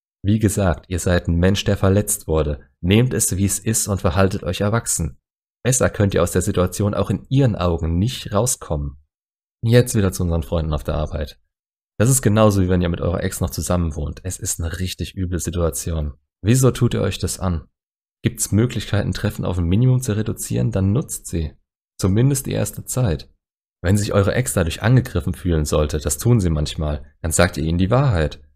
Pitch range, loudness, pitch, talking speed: 80-105 Hz, -20 LUFS, 95 Hz, 200 wpm